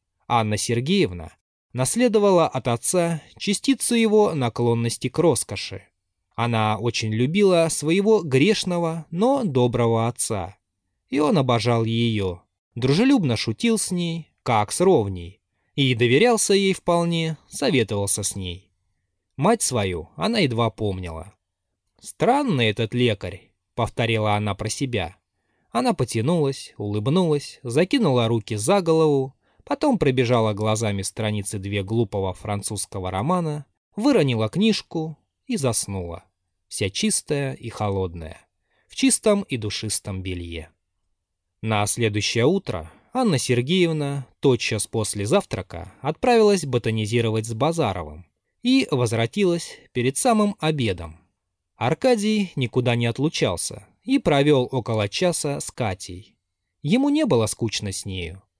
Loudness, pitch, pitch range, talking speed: -22 LUFS, 120 Hz, 100-160 Hz, 110 wpm